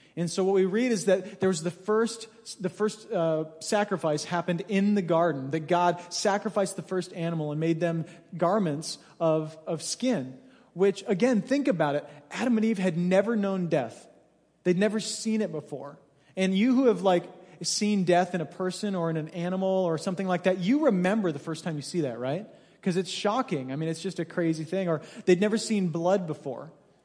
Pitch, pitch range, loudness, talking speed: 185 Hz, 165-205 Hz, -27 LUFS, 205 wpm